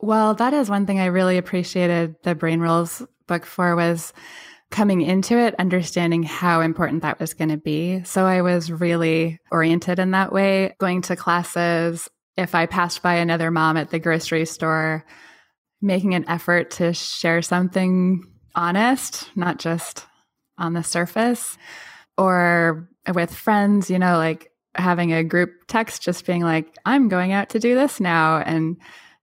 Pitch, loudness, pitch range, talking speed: 175 Hz, -20 LUFS, 165-185 Hz, 160 wpm